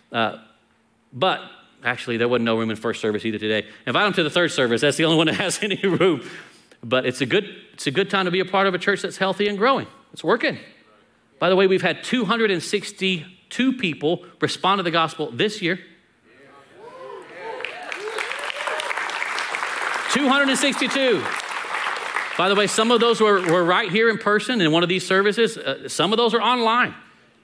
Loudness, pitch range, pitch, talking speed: -21 LUFS, 160-225 Hz, 190 Hz, 180 wpm